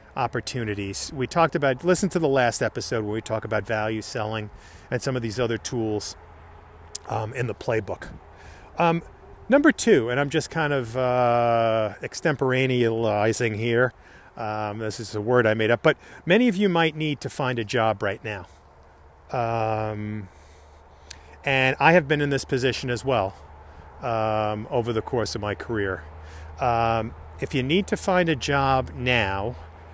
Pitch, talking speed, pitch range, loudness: 115 Hz, 165 wpm, 100-135 Hz, -24 LUFS